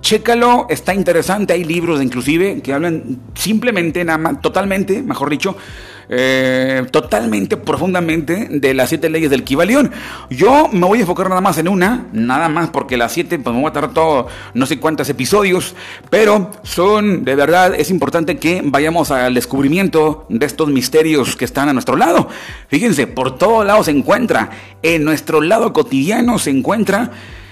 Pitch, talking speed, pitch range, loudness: 165 Hz, 170 wpm, 140-190 Hz, -14 LUFS